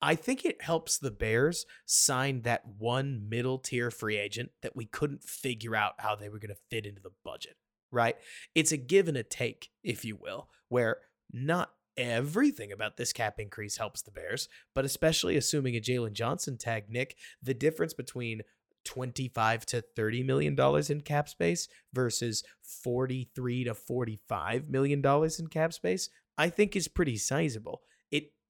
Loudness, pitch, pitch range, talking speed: -31 LUFS, 125 Hz, 115-145 Hz, 170 wpm